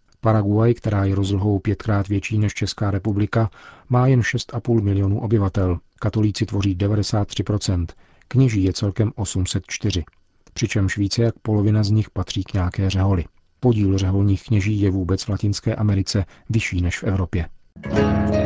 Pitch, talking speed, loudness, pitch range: 100 Hz, 140 wpm, -21 LUFS, 95-110 Hz